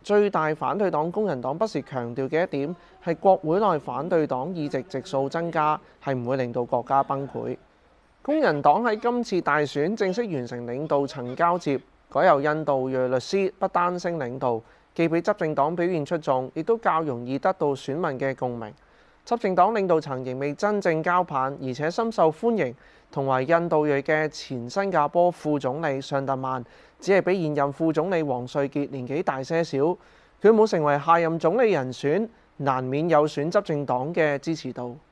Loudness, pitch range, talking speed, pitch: -24 LUFS, 135-175 Hz, 270 characters per minute, 150 Hz